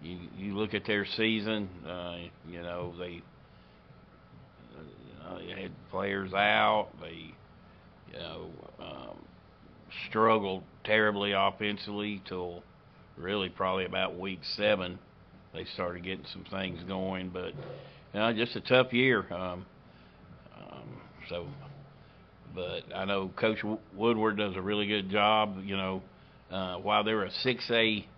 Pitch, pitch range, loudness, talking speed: 100 Hz, 90-110 Hz, -31 LUFS, 135 wpm